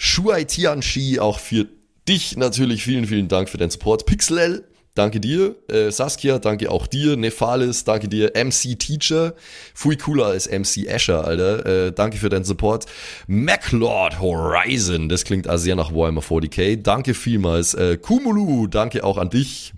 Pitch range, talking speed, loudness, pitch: 100-130 Hz, 155 wpm, -19 LUFS, 110 Hz